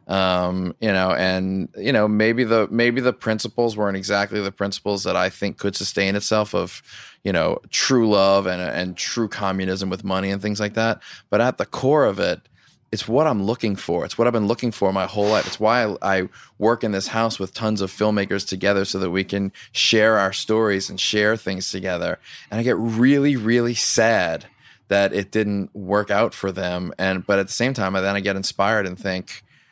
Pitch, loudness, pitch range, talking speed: 100 Hz, -21 LUFS, 95-110 Hz, 215 wpm